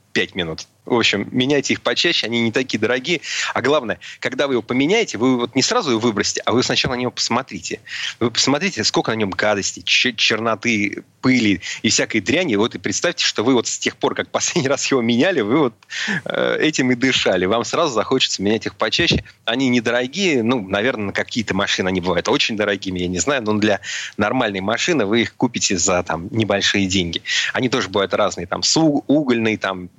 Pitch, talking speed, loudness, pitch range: 110 Hz, 200 wpm, -18 LUFS, 100-125 Hz